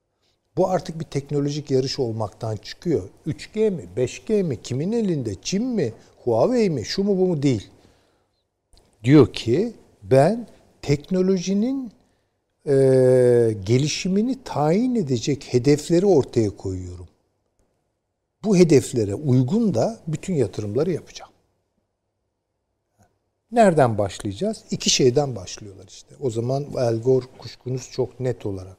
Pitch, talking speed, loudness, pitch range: 125 Hz, 110 wpm, -21 LUFS, 105-170 Hz